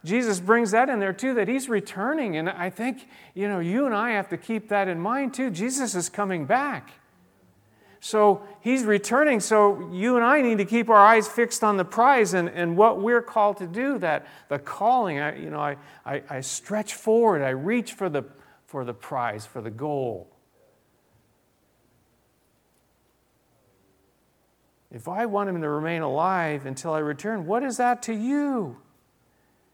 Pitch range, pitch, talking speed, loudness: 165-235 Hz, 205 Hz, 175 wpm, -24 LUFS